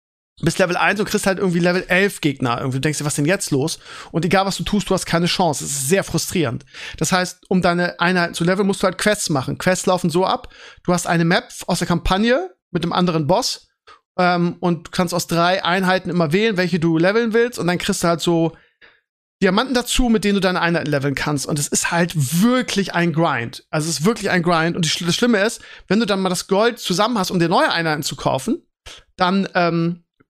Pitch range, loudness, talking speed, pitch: 170-195 Hz, -19 LUFS, 235 wpm, 180 Hz